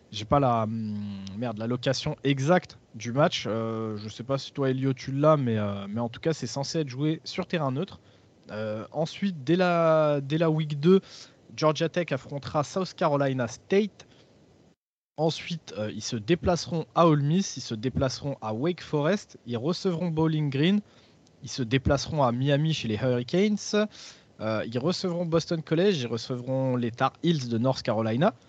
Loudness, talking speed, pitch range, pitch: -27 LUFS, 175 wpm, 120-165 Hz, 140 Hz